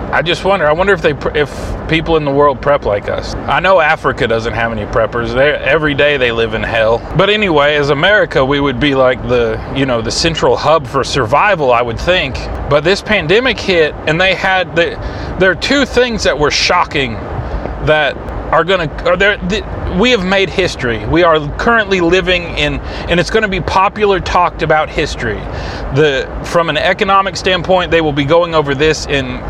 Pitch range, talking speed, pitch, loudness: 140-190 Hz, 200 wpm, 160 Hz, -12 LUFS